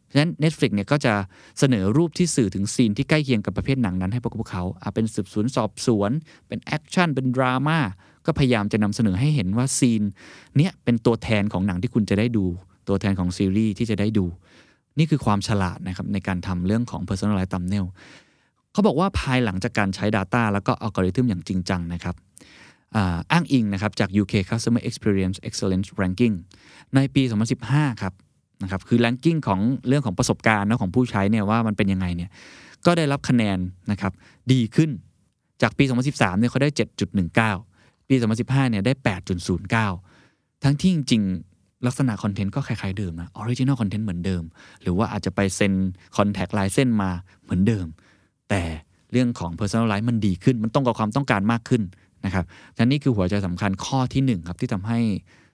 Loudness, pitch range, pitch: -23 LUFS, 95-125 Hz, 110 Hz